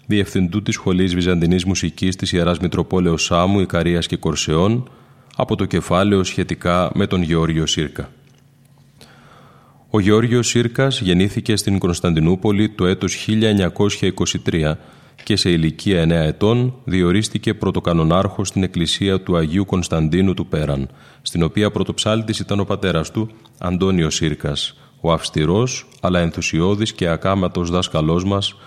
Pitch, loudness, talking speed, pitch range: 95 Hz, -18 LUFS, 125 wpm, 85-110 Hz